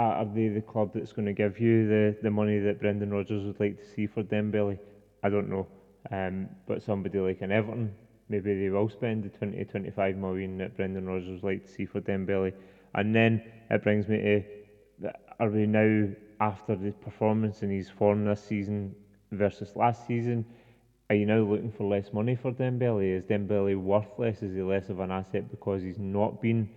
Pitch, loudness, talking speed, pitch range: 105 Hz, -29 LUFS, 200 wpm, 100-110 Hz